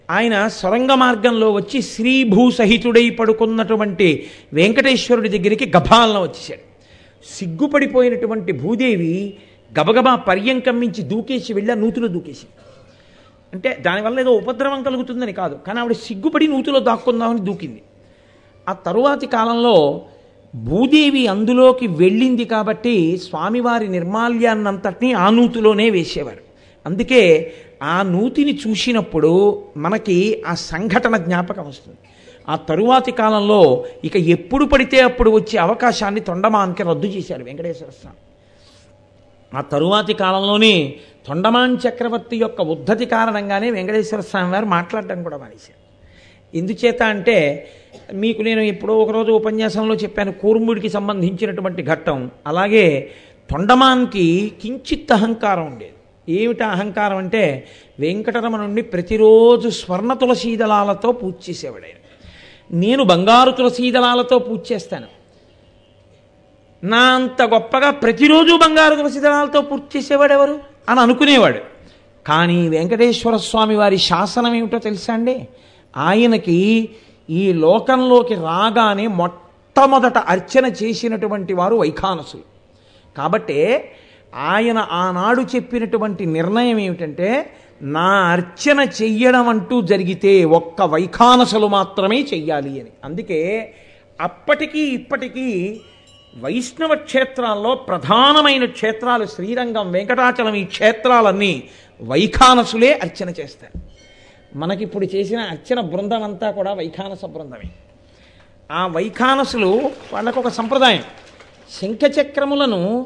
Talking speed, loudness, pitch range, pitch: 100 wpm, -16 LUFS, 185-245 Hz, 220 Hz